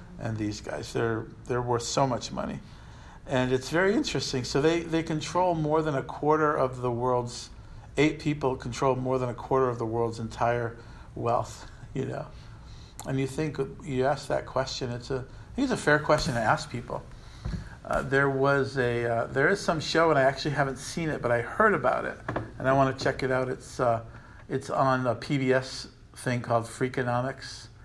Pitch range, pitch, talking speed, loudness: 120-140 Hz, 130 Hz, 200 wpm, -28 LUFS